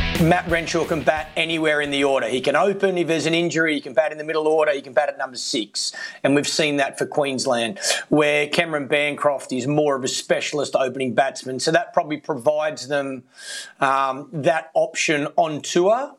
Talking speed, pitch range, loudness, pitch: 200 wpm, 140-165 Hz, -21 LUFS, 150 Hz